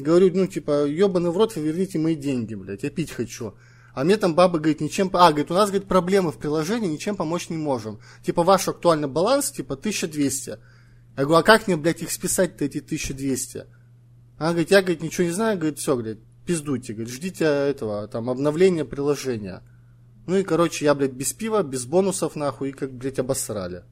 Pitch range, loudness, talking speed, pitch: 125-180 Hz, -23 LUFS, 200 wpm, 150 Hz